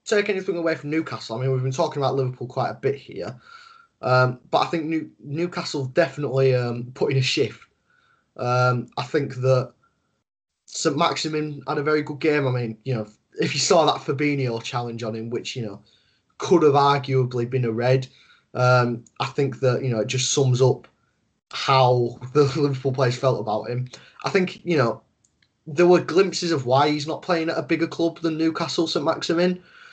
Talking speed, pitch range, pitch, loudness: 195 wpm, 125-165 Hz, 135 Hz, -22 LUFS